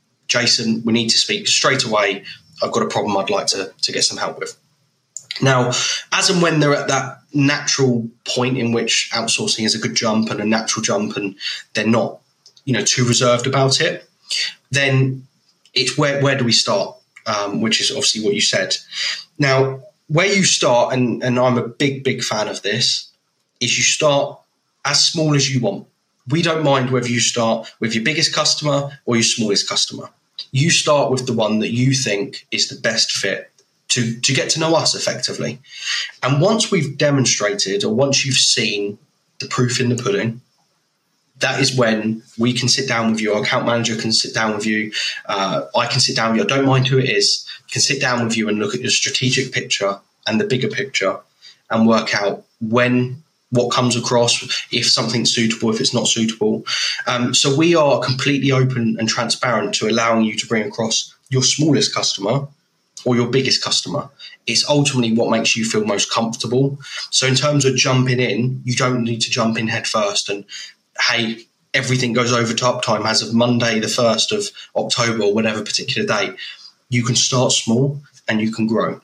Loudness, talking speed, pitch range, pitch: -17 LUFS, 195 wpm, 115-135 Hz, 125 Hz